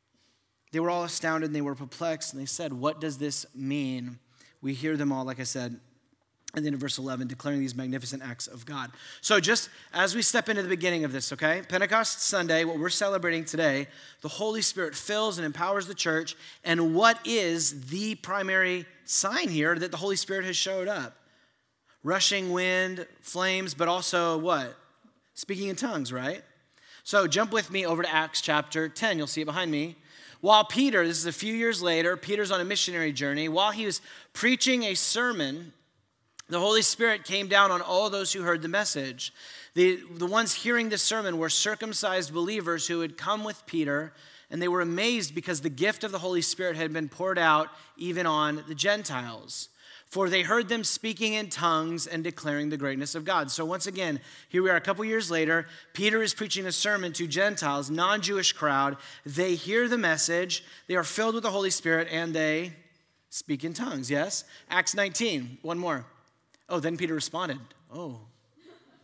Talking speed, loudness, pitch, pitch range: 190 wpm, -27 LUFS, 170 Hz, 155-200 Hz